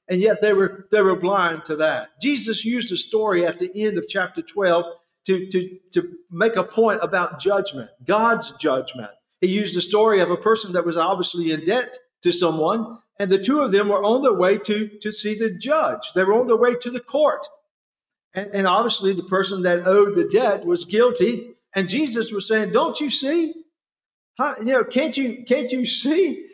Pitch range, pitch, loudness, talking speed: 180-245 Hz, 210 Hz, -21 LUFS, 205 wpm